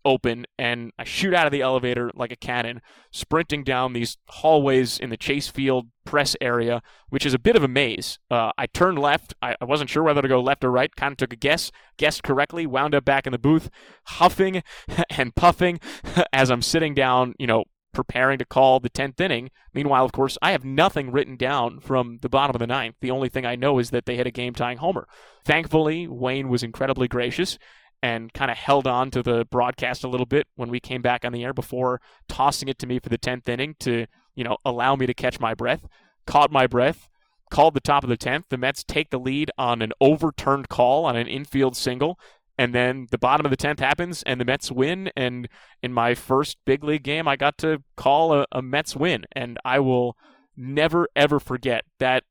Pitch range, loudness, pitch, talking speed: 125-145 Hz, -22 LUFS, 130 Hz, 220 wpm